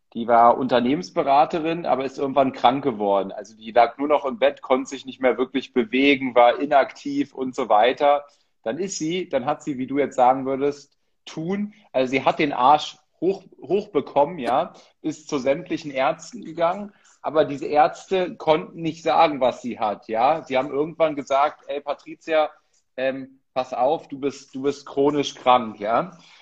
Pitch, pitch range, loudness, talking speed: 140 Hz, 130-155 Hz, -22 LUFS, 175 wpm